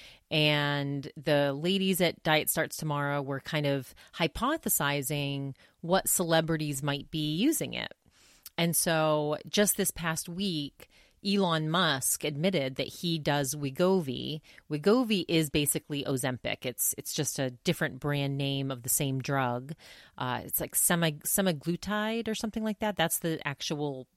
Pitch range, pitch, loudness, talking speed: 140-175 Hz, 155 Hz, -29 LUFS, 140 wpm